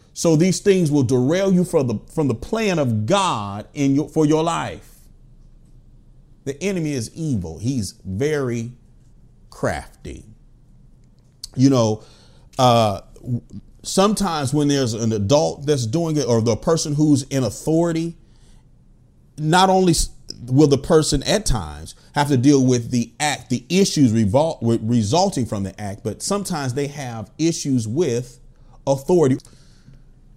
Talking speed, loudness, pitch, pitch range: 135 wpm, -20 LUFS, 135 Hz, 120-160 Hz